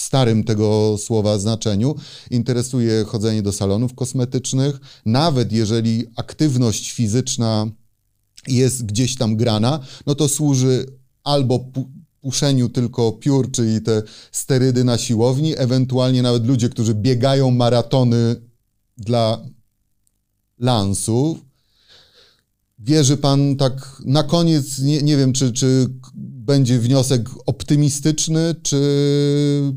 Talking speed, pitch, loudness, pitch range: 105 wpm, 125 Hz, -18 LUFS, 115-135 Hz